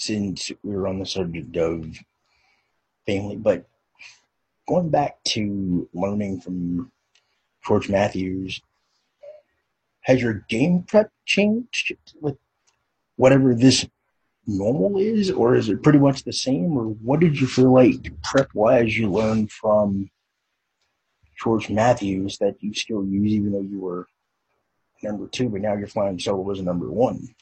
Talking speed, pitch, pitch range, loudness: 140 wpm, 105 Hz, 95-130 Hz, -22 LUFS